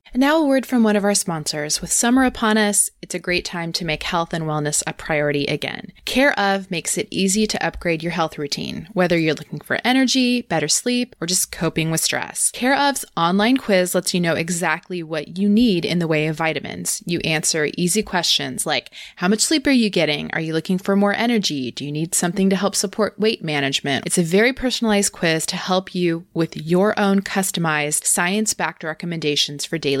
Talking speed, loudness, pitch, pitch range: 210 wpm, -19 LUFS, 180 Hz, 160-210 Hz